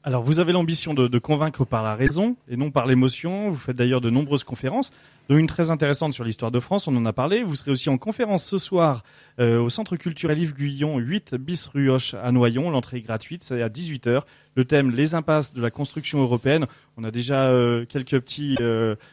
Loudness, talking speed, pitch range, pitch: -23 LUFS, 225 wpm, 125-160 Hz, 140 Hz